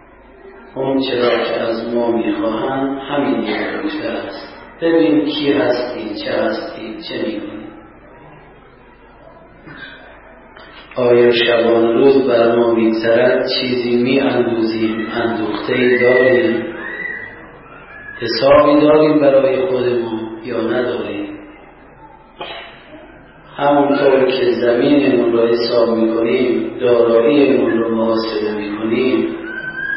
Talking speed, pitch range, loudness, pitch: 80 wpm, 115-140 Hz, -15 LUFS, 120 Hz